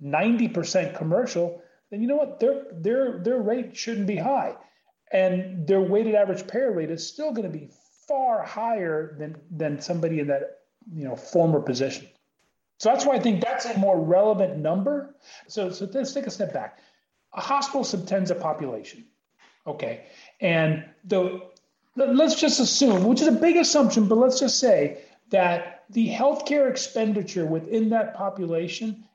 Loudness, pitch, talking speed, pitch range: -24 LUFS, 215 Hz, 160 wpm, 175-260 Hz